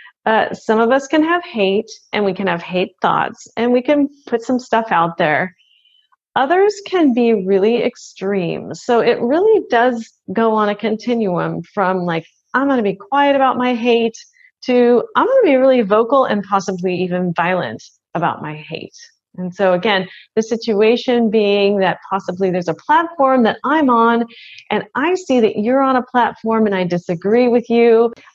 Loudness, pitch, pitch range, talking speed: -16 LUFS, 230 Hz, 195-255 Hz, 175 wpm